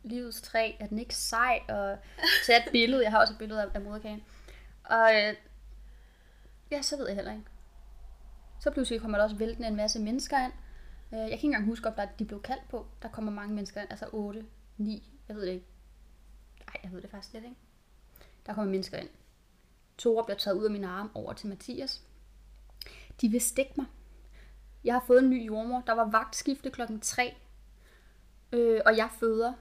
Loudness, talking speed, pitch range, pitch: -29 LUFS, 195 wpm, 205-240 Hz, 220 Hz